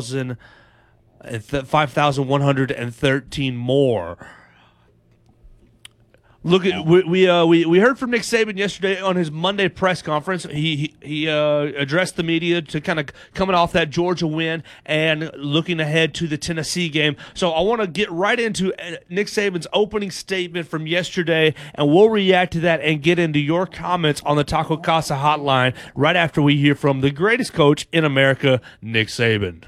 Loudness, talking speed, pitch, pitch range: -19 LUFS, 165 wpm, 160 Hz, 140-180 Hz